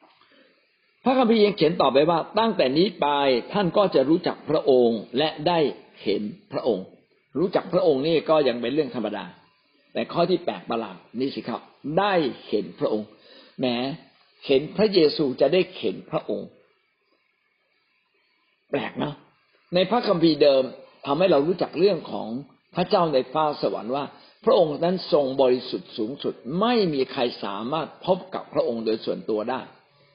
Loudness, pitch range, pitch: -23 LUFS, 130-185 Hz, 155 Hz